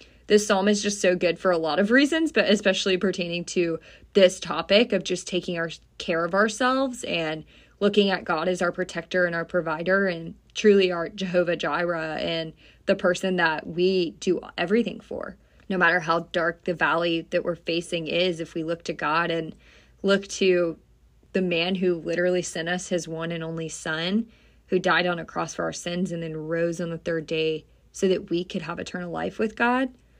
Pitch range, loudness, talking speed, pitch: 165-190 Hz, -25 LUFS, 200 wpm, 175 Hz